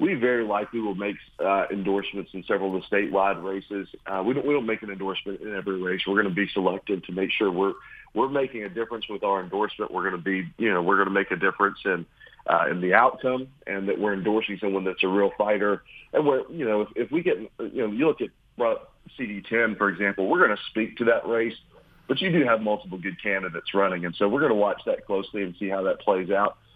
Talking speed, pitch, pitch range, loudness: 250 wpm, 100 Hz, 95-110 Hz, -25 LUFS